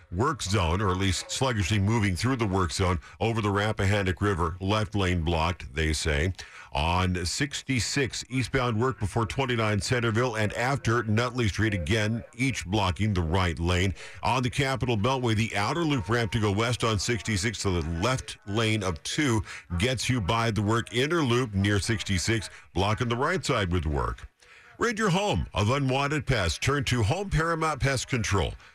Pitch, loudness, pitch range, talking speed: 110 Hz, -27 LUFS, 95-125 Hz, 175 wpm